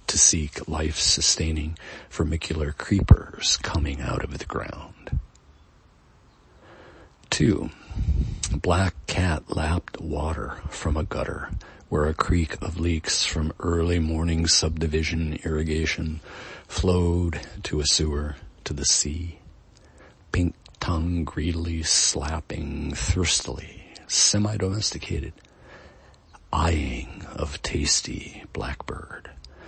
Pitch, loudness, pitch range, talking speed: 80 Hz, -24 LUFS, 75-85 Hz, 90 wpm